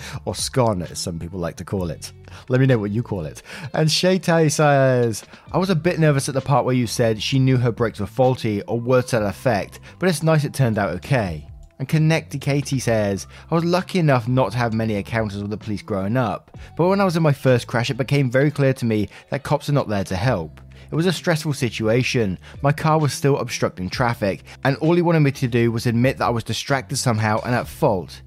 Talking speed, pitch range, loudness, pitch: 245 wpm, 105-140 Hz, -20 LUFS, 125 Hz